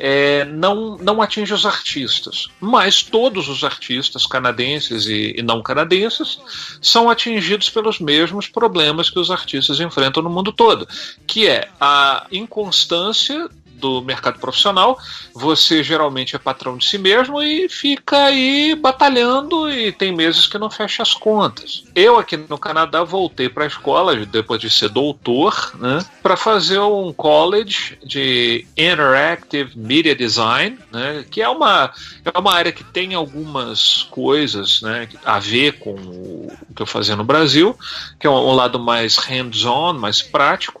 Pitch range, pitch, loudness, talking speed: 130-210 Hz, 160 Hz, -15 LUFS, 155 wpm